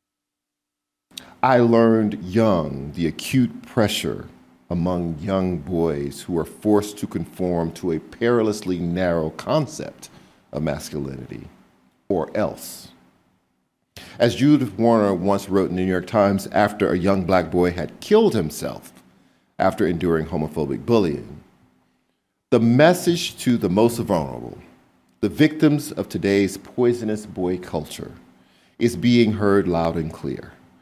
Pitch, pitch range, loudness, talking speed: 90 Hz, 80-110 Hz, -21 LUFS, 125 wpm